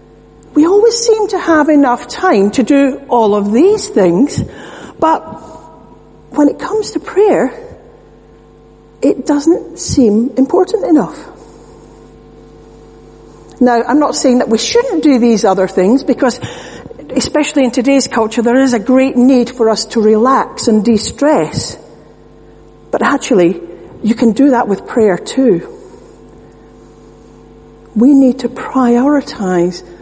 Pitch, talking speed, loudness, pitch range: 260 Hz, 130 wpm, -11 LUFS, 230-300 Hz